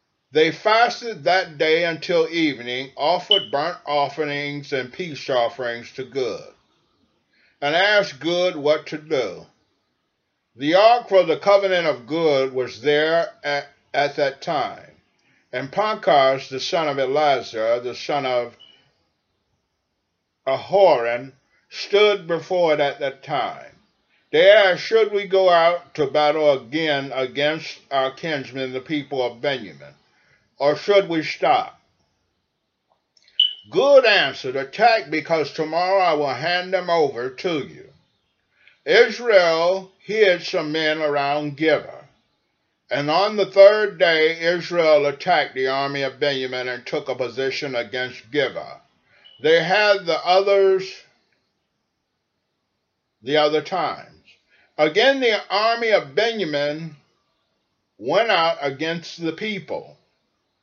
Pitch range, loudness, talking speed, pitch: 135-190 Hz, -20 LUFS, 120 wpm, 155 Hz